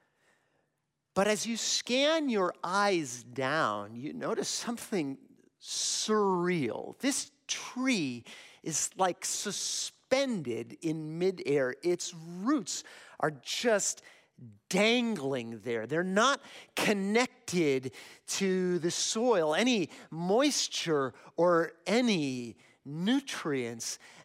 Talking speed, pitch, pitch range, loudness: 85 wpm, 185 Hz, 145-230 Hz, -31 LUFS